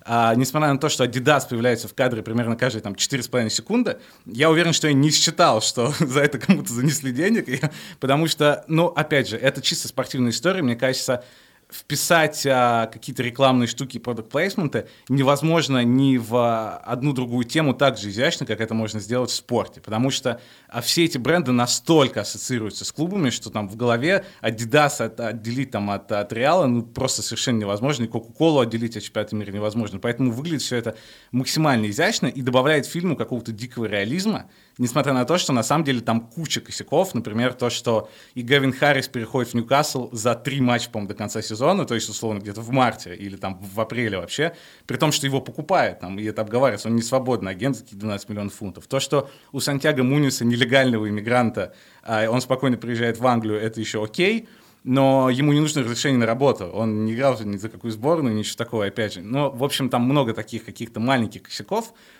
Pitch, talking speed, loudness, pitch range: 125 Hz, 195 wpm, -22 LUFS, 115-140 Hz